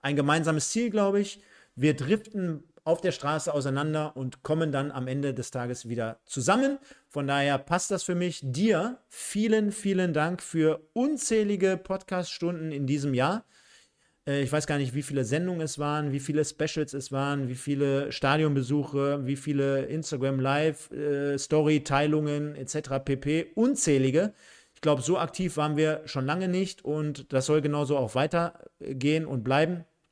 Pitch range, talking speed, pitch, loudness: 140-175 Hz, 150 wpm, 150 Hz, -28 LUFS